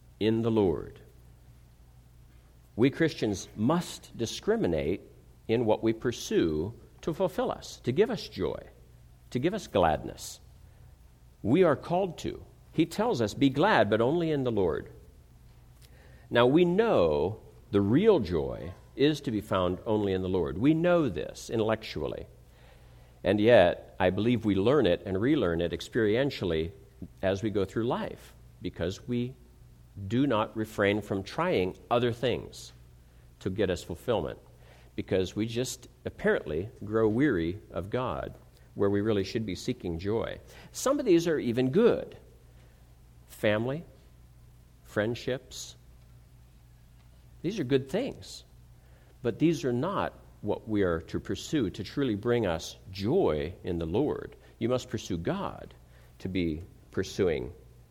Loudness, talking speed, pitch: -29 LUFS, 140 wpm, 95 Hz